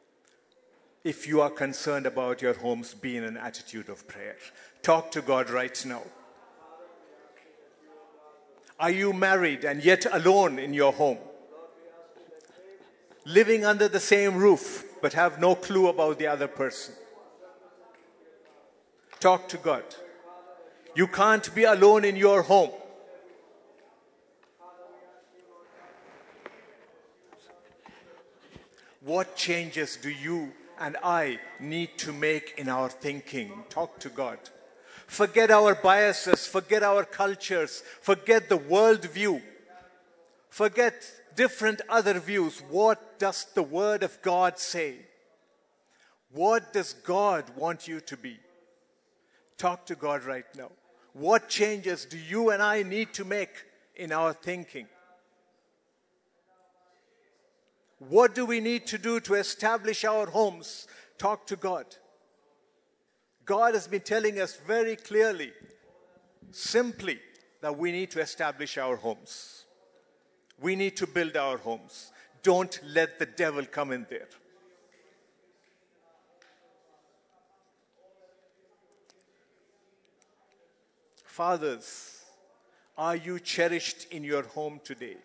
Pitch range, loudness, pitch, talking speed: 165-220 Hz, -26 LUFS, 185 Hz, 110 wpm